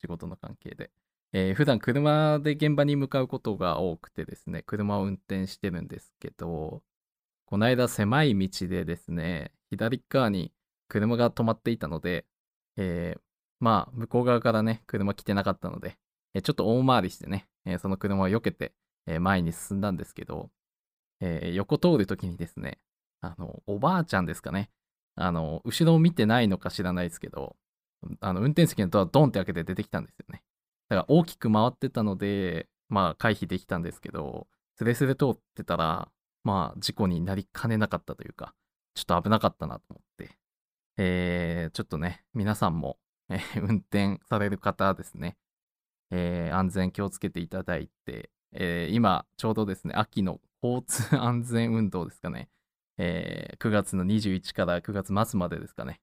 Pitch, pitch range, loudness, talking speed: 100 Hz, 90-115 Hz, -28 LUFS, 335 characters per minute